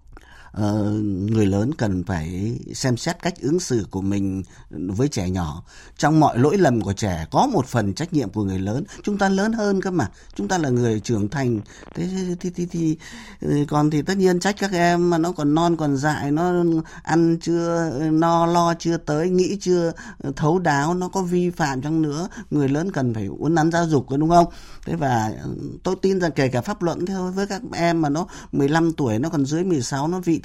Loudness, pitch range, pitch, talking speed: -22 LUFS, 120-175 Hz, 155 Hz, 215 wpm